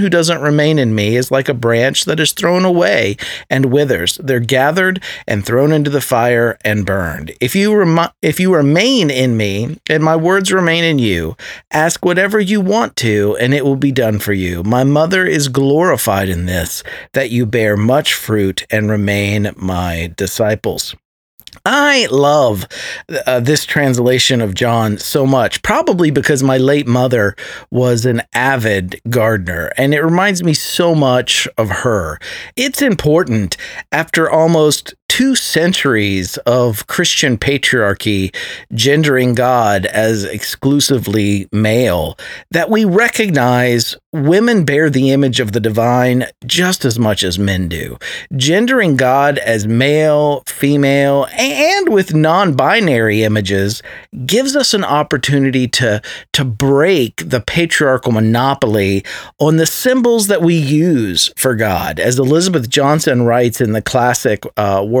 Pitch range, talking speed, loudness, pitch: 115-160 Hz, 145 wpm, -13 LUFS, 135 Hz